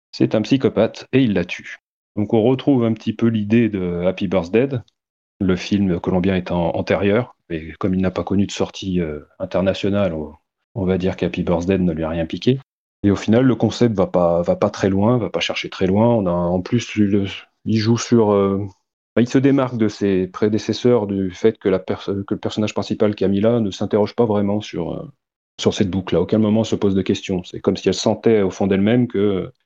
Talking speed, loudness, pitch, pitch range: 220 wpm, -19 LUFS, 100 Hz, 95-110 Hz